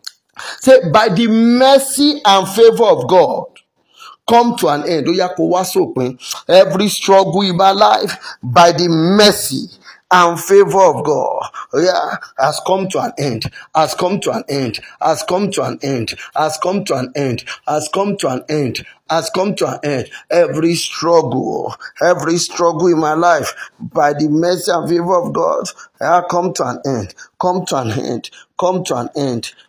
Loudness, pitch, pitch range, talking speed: -14 LUFS, 175 Hz, 150-195 Hz, 165 wpm